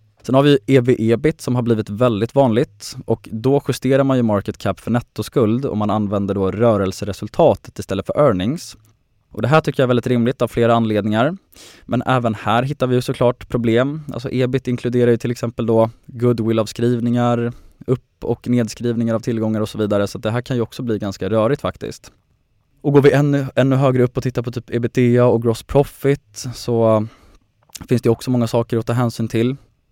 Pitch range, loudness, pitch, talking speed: 110-130 Hz, -18 LUFS, 120 Hz, 190 wpm